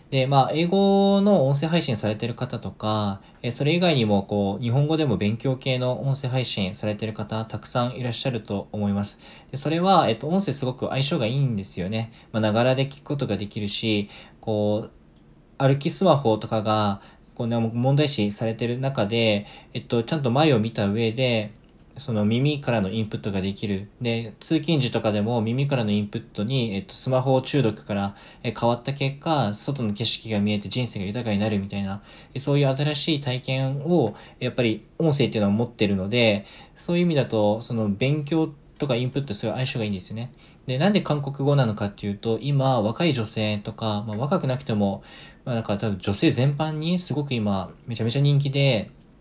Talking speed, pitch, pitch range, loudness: 385 characters per minute, 120 Hz, 105-135 Hz, -24 LUFS